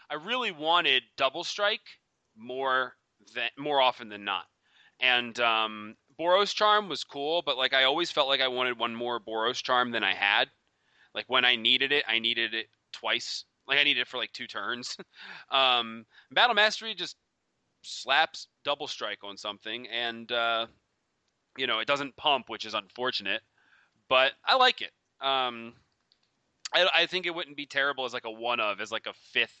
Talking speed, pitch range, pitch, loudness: 180 wpm, 115-150 Hz, 130 Hz, -27 LUFS